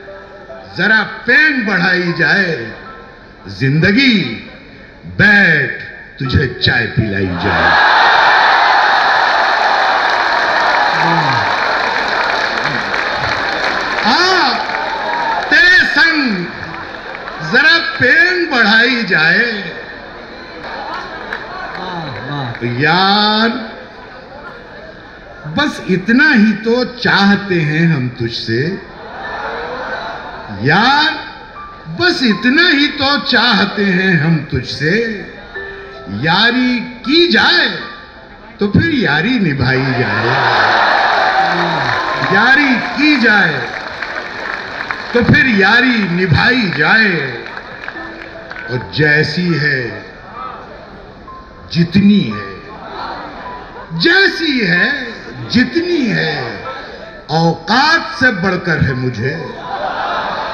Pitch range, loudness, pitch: 160-250 Hz, -12 LUFS, 200 Hz